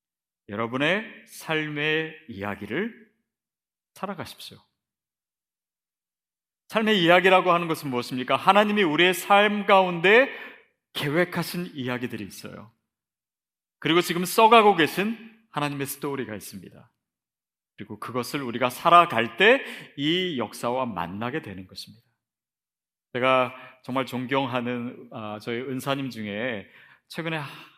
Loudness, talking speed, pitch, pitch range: -23 LUFS, 260 characters per minute, 140 Hz, 120-175 Hz